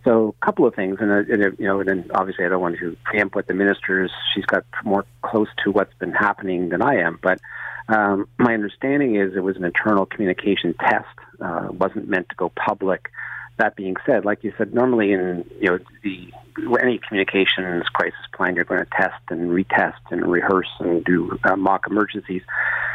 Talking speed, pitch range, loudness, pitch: 195 wpm, 95-105 Hz, -21 LUFS, 100 Hz